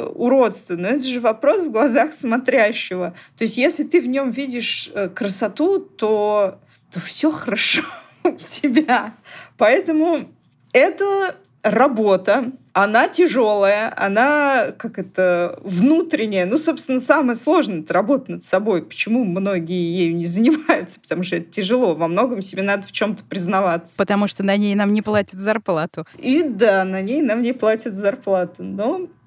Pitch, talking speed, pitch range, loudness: 225 Hz, 150 wpm, 195-290 Hz, -19 LUFS